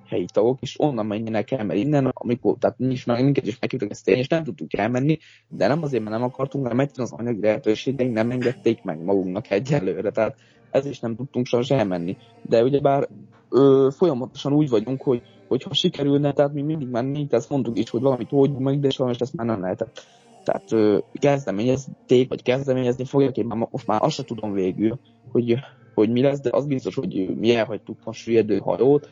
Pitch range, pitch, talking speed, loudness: 110-135 Hz, 120 Hz, 200 wpm, -22 LUFS